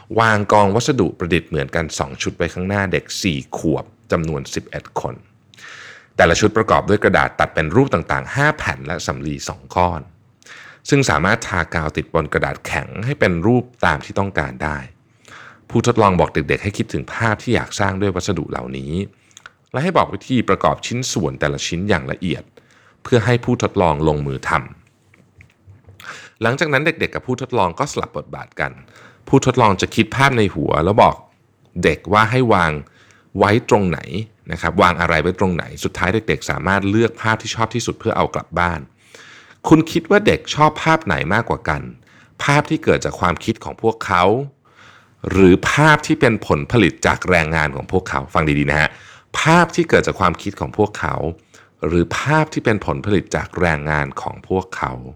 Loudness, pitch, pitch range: -18 LUFS, 100 Hz, 80-120 Hz